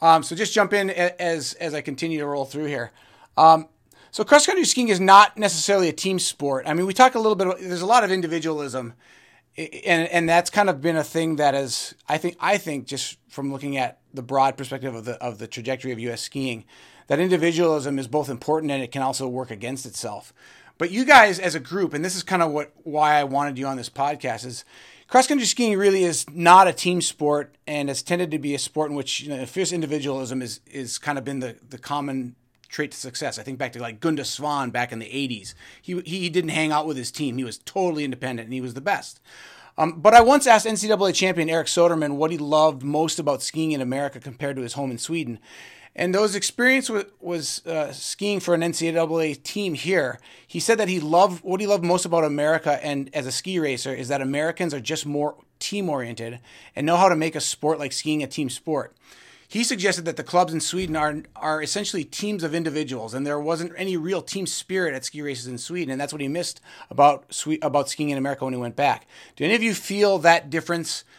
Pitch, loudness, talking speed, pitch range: 155 Hz, -22 LUFS, 235 wpm, 135-180 Hz